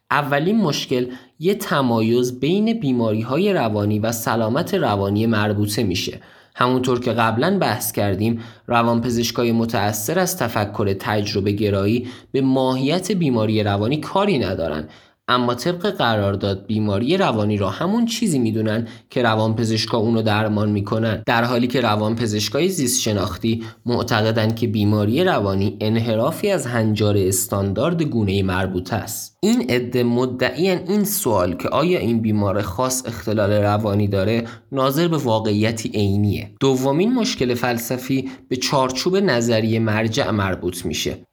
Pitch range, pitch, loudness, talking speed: 105-130 Hz, 115 Hz, -20 LUFS, 130 wpm